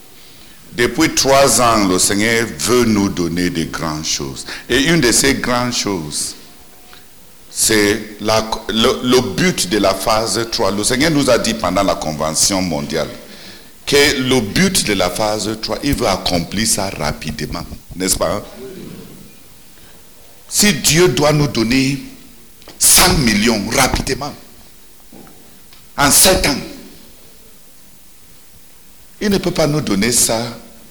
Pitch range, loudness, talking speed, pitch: 95-130 Hz, -14 LUFS, 130 wpm, 110 Hz